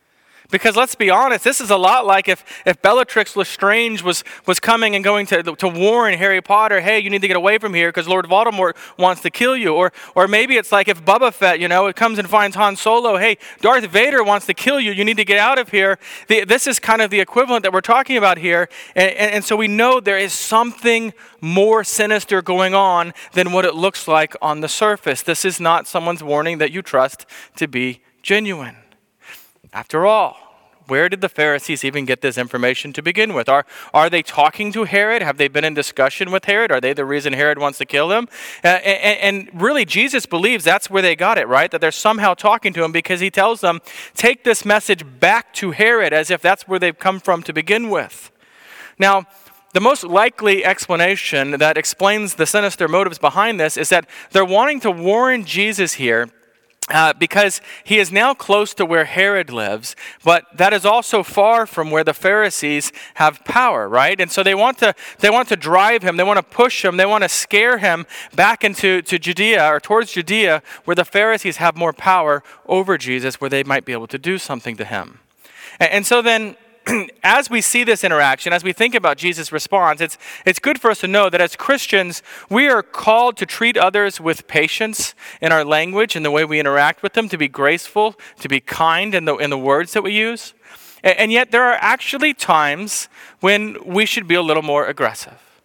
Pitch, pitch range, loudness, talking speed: 190 Hz, 160-215 Hz, -15 LUFS, 215 wpm